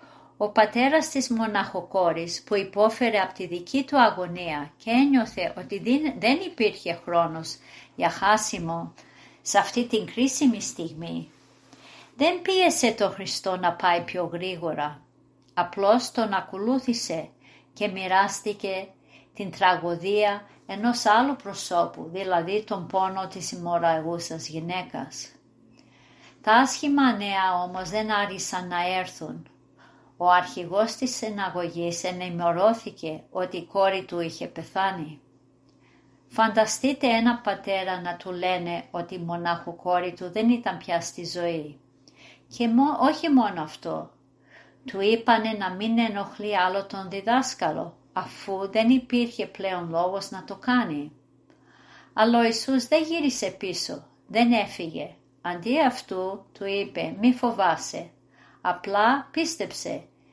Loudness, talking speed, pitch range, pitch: -25 LUFS, 120 wpm, 175-225 Hz, 195 Hz